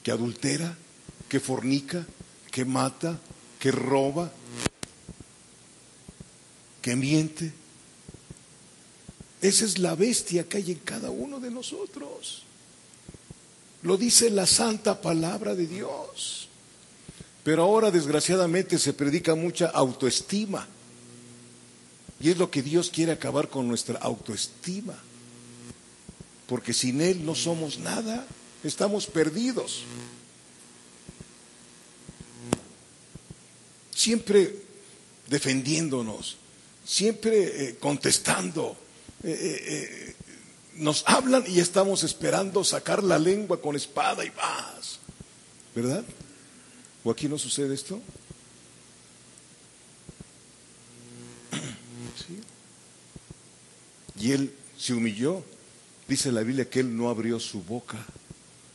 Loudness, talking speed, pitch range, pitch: -27 LUFS, 90 wpm, 115-180 Hz, 140 Hz